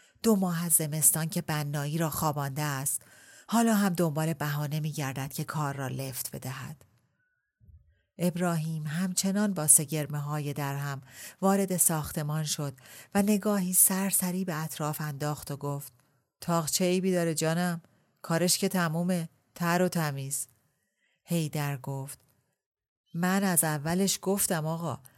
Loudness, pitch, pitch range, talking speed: -28 LUFS, 160 Hz, 145-180 Hz, 130 wpm